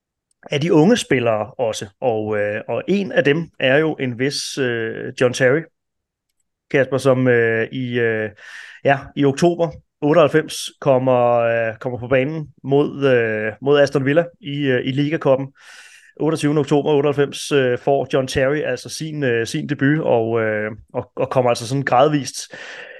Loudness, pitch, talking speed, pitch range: -18 LUFS, 135 Hz, 155 wpm, 120-145 Hz